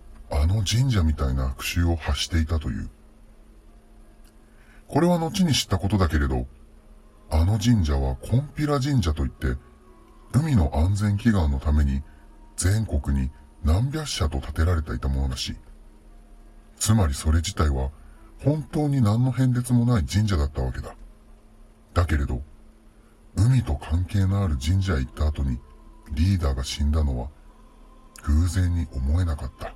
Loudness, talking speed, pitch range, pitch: -24 LUFS, 280 characters per minute, 75-110 Hz, 85 Hz